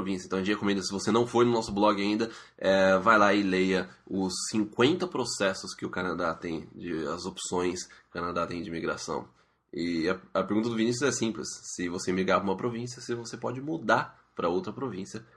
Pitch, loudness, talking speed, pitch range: 100 Hz, -29 LUFS, 205 wpm, 95-115 Hz